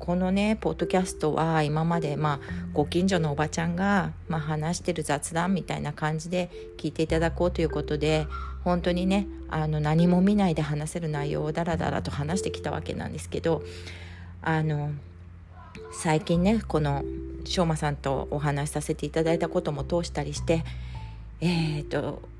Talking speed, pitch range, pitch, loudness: 345 characters per minute, 145-170 Hz, 155 Hz, -27 LUFS